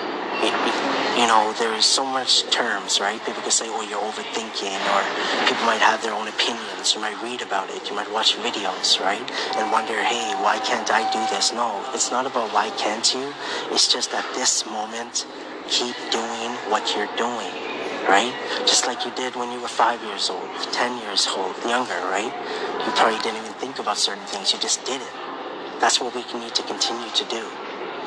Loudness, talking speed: -22 LUFS, 200 wpm